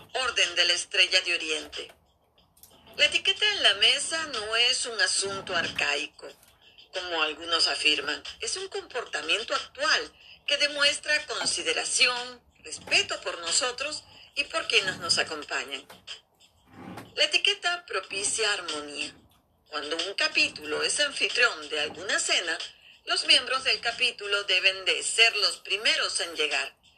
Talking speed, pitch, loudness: 125 wpm, 250 Hz, -25 LUFS